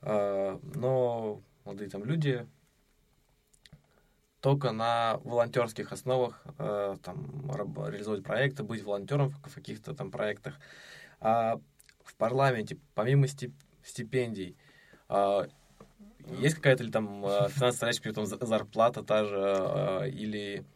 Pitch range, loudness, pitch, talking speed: 105-130 Hz, -31 LUFS, 115 Hz, 100 wpm